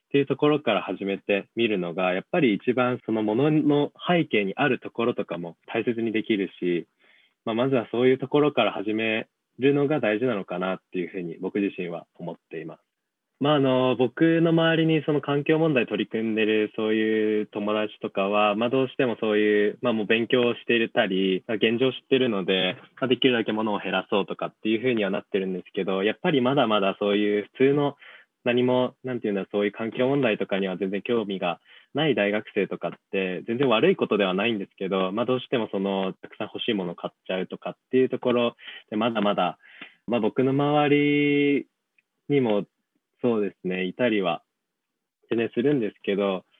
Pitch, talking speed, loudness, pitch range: 115 Hz, 405 characters per minute, -24 LUFS, 100-130 Hz